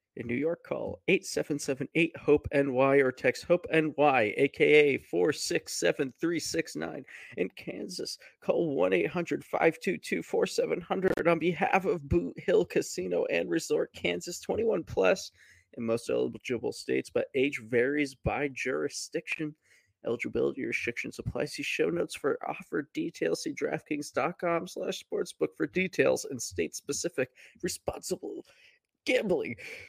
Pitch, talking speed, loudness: 170 Hz, 110 wpm, -30 LUFS